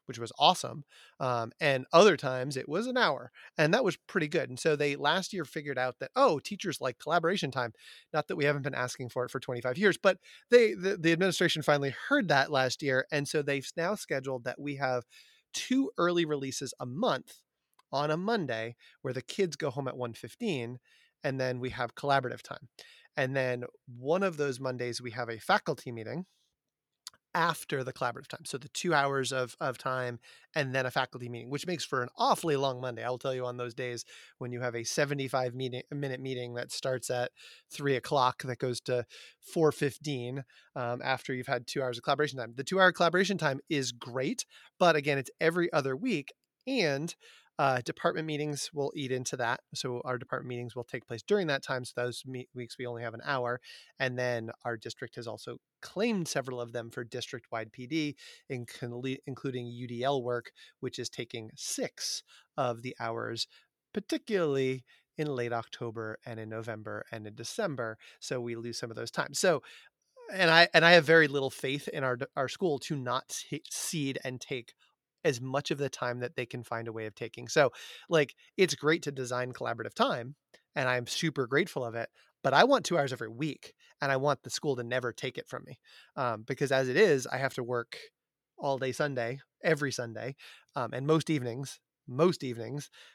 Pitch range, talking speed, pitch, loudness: 125-150 Hz, 200 wpm, 130 Hz, -31 LUFS